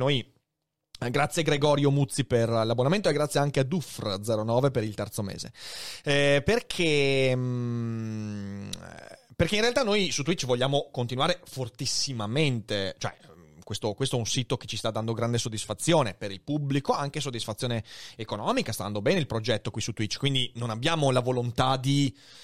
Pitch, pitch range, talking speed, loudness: 125 Hz, 115-140 Hz, 155 wpm, -27 LUFS